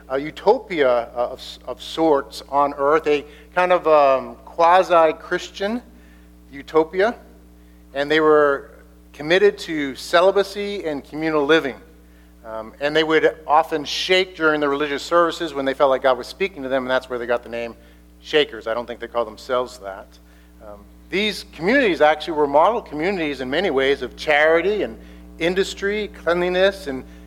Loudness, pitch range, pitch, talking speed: -20 LUFS, 115-160 Hz, 140 Hz, 160 wpm